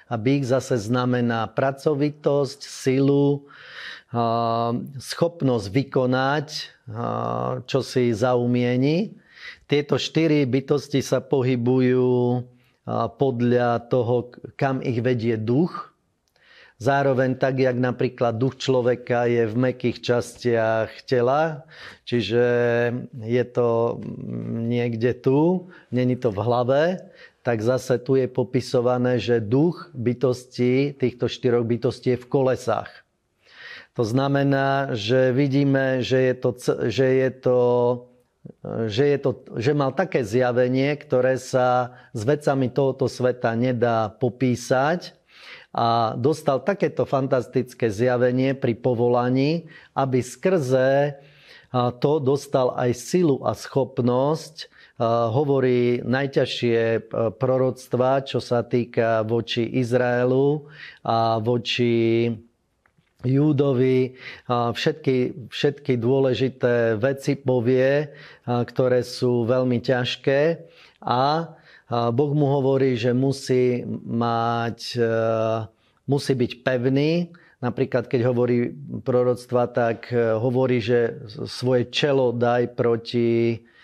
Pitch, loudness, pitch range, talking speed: 125 Hz, -22 LUFS, 120-135 Hz, 100 wpm